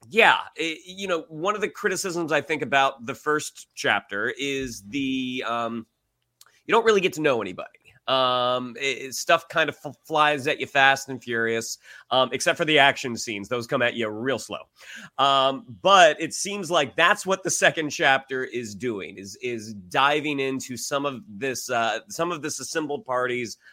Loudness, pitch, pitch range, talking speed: -23 LUFS, 135 Hz, 125-160 Hz, 185 wpm